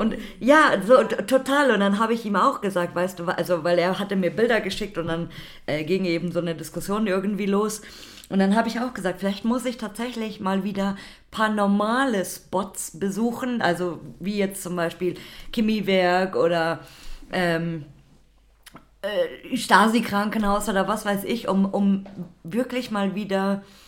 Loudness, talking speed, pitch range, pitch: -23 LUFS, 165 wpm, 180-220 Hz, 195 Hz